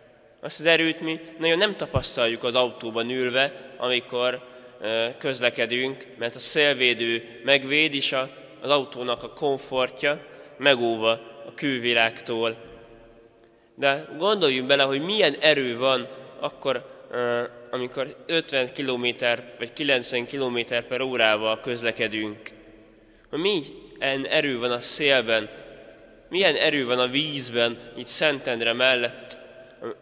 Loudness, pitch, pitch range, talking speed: -23 LUFS, 125 Hz, 115-140 Hz, 110 wpm